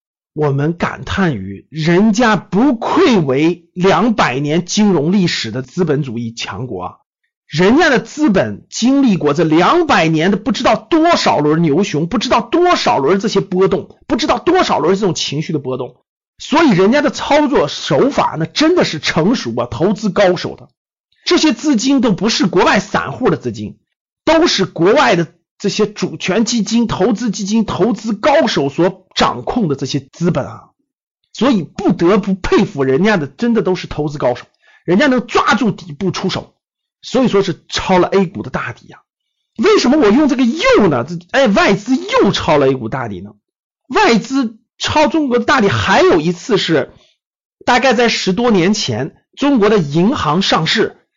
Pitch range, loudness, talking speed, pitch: 165-255 Hz, -14 LUFS, 260 characters per minute, 200 Hz